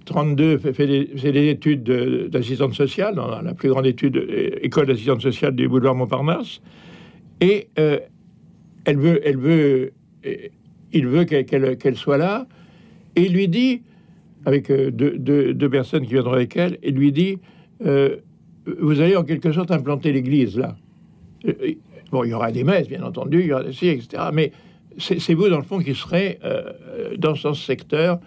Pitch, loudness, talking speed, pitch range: 150 Hz, -20 LUFS, 185 wpm, 140-180 Hz